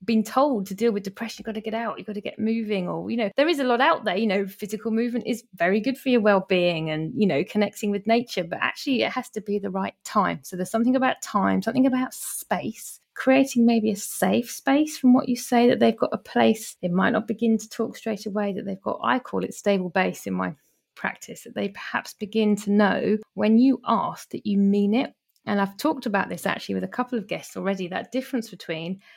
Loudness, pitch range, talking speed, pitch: -24 LUFS, 195-240 Hz, 245 wpm, 215 Hz